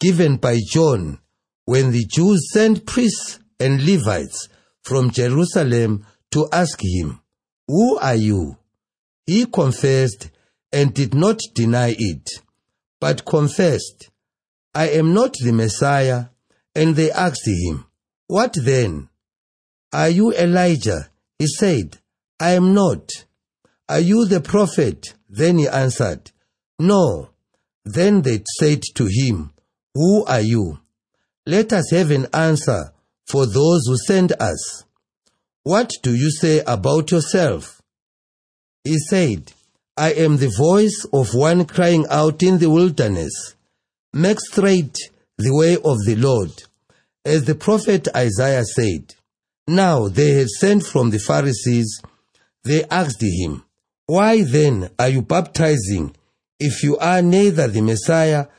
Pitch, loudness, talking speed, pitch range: 145 Hz, -17 LUFS, 125 wpm, 115-175 Hz